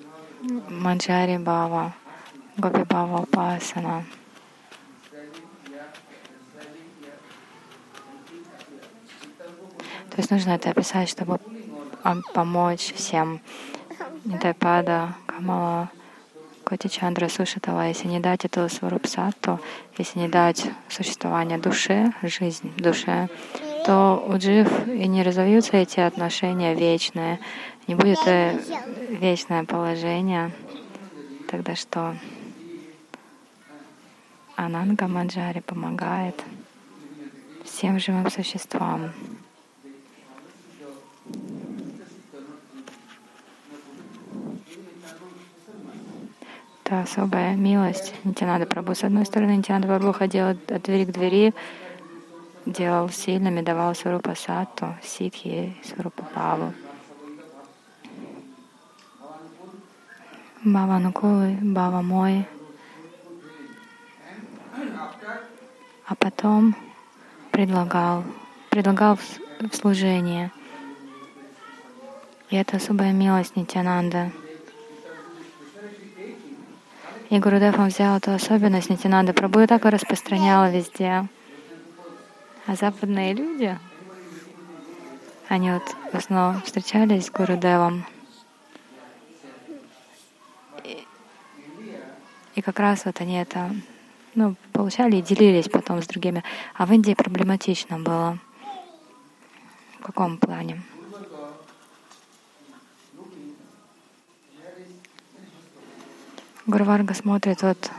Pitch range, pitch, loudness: 175-220 Hz, 190 Hz, -23 LUFS